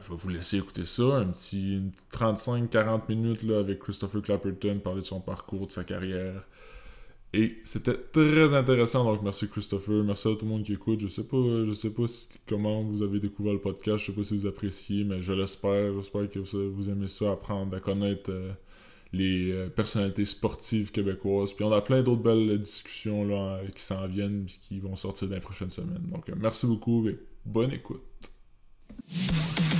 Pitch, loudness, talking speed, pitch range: 100 Hz, -29 LUFS, 205 wpm, 95-110 Hz